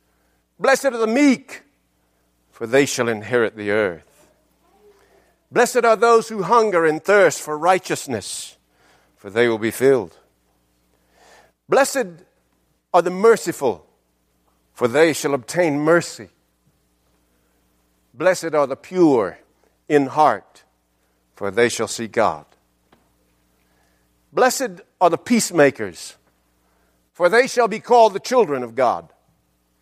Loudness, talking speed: -18 LUFS, 115 wpm